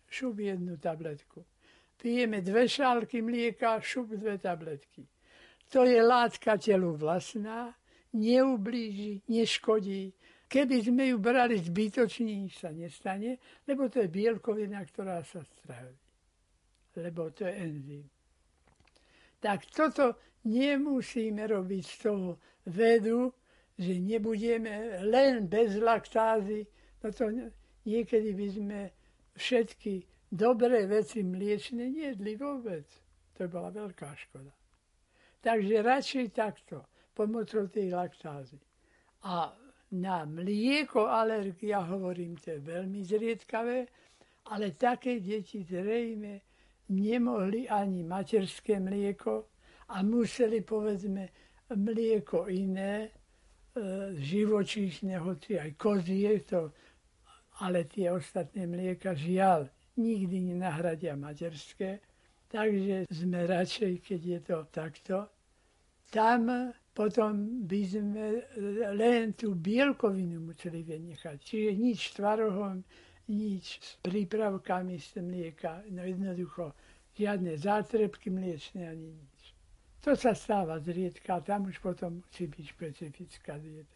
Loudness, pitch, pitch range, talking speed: -32 LUFS, 205 Hz, 180-225 Hz, 105 wpm